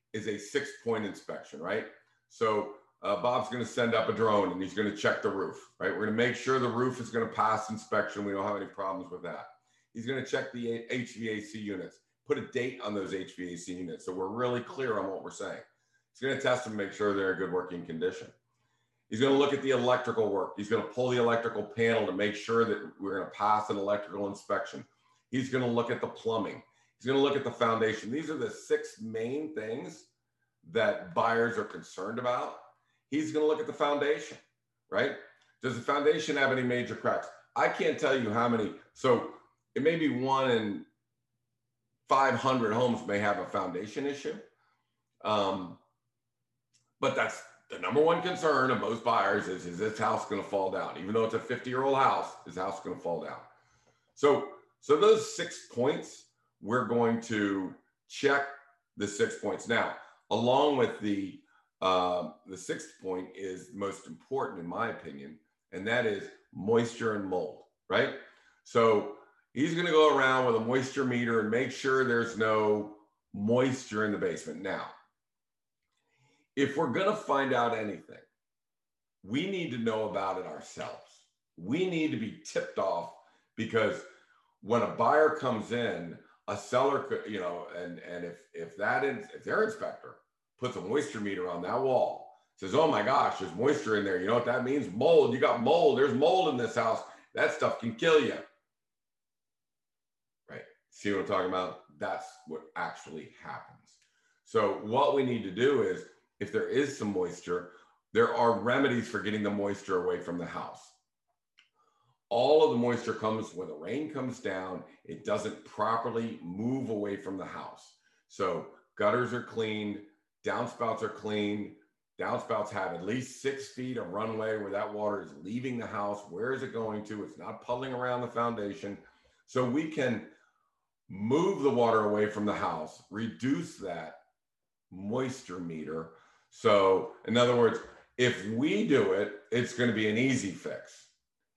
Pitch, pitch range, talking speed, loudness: 120 Hz, 105-135 Hz, 180 wpm, -31 LUFS